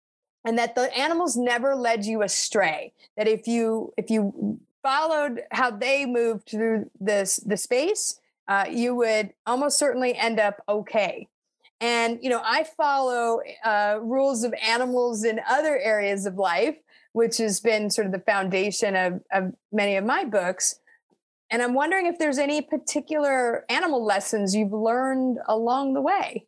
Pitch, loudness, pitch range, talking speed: 230 Hz, -24 LUFS, 215-270 Hz, 160 wpm